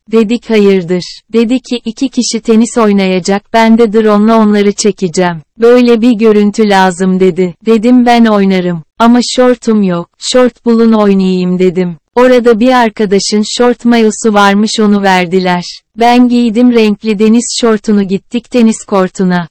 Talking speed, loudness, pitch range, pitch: 135 wpm, -8 LUFS, 190-235 Hz, 220 Hz